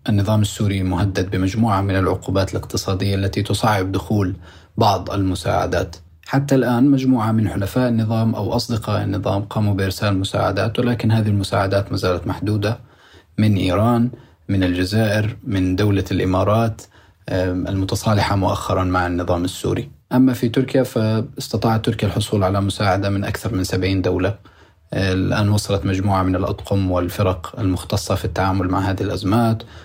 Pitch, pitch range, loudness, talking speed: 100 Hz, 95-110 Hz, -19 LUFS, 135 wpm